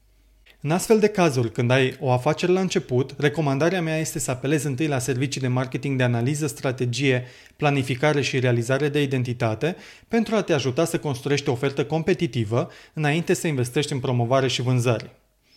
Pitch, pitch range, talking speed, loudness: 145 Hz, 130-160 Hz, 170 wpm, -23 LUFS